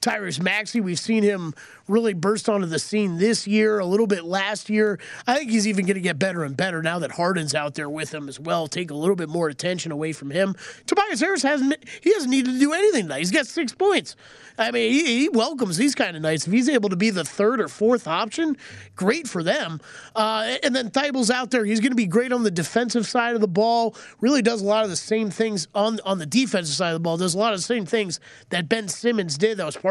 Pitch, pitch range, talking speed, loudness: 215 Hz, 180-240 Hz, 260 wpm, -22 LUFS